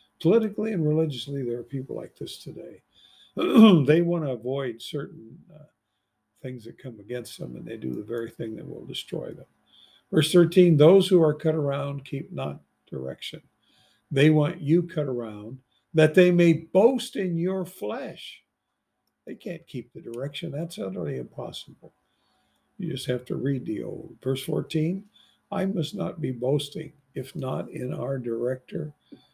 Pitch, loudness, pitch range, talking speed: 150 Hz, -25 LUFS, 130-170 Hz, 160 wpm